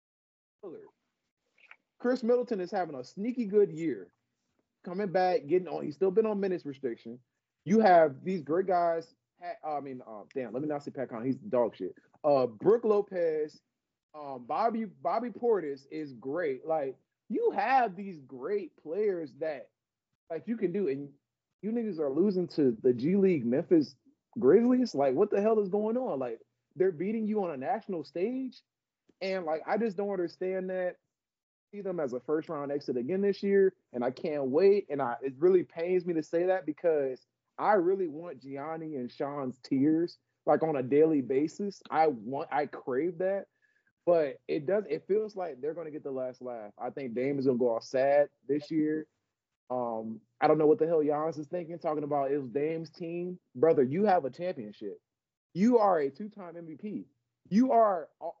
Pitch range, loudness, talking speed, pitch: 145-225 Hz, -30 LUFS, 185 wpm, 180 Hz